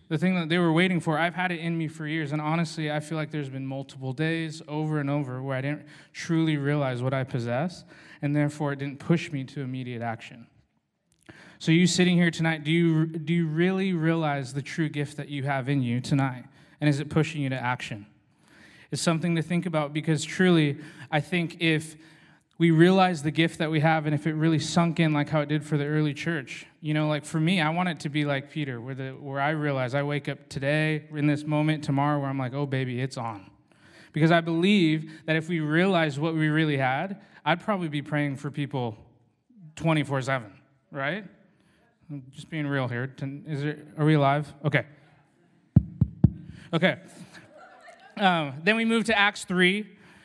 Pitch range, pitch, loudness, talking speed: 140-165 Hz, 150 Hz, -26 LUFS, 205 wpm